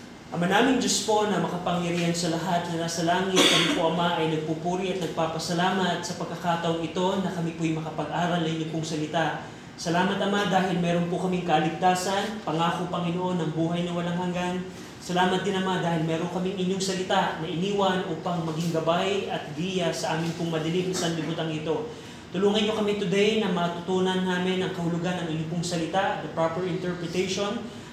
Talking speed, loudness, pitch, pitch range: 170 wpm, -26 LUFS, 175 Hz, 165-185 Hz